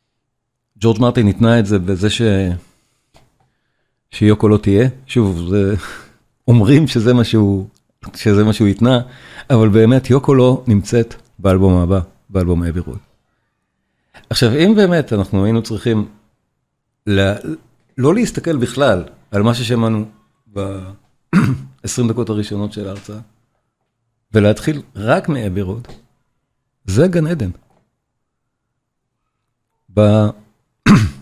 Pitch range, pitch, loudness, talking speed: 105-125 Hz, 115 Hz, -15 LUFS, 105 wpm